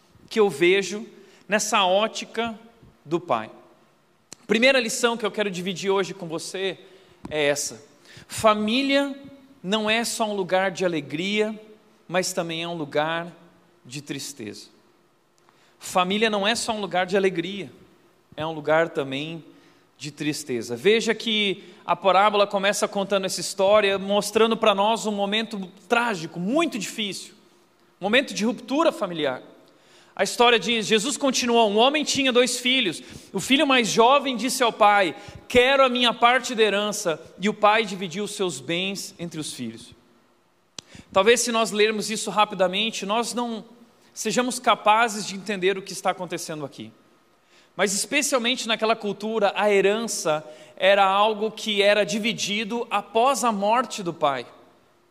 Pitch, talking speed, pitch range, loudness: 205 Hz, 145 wpm, 180-225 Hz, -22 LUFS